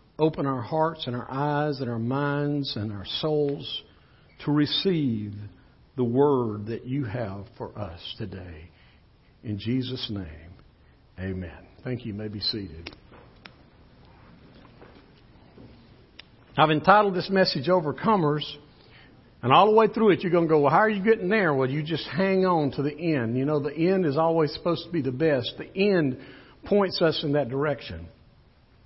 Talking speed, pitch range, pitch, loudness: 165 wpm, 110-160 Hz, 140 Hz, -25 LUFS